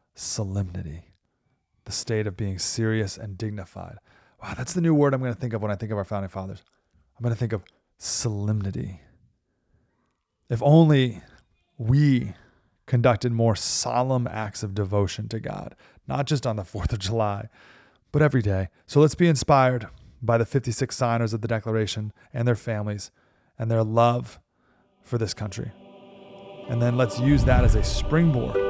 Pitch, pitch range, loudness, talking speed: 115 Hz, 100-125 Hz, -24 LUFS, 165 wpm